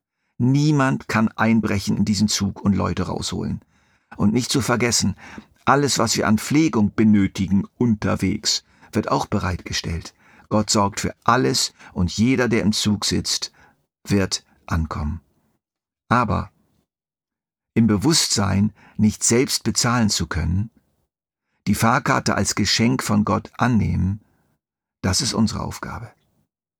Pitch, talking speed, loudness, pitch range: 105 Hz, 120 wpm, -20 LUFS, 95-115 Hz